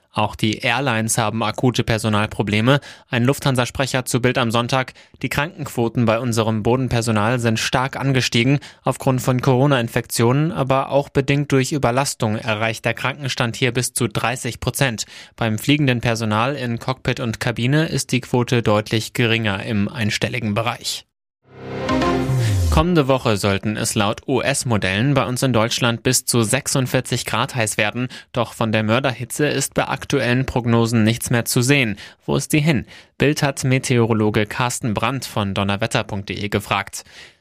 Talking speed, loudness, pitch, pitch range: 145 wpm, -19 LUFS, 120 Hz, 110-135 Hz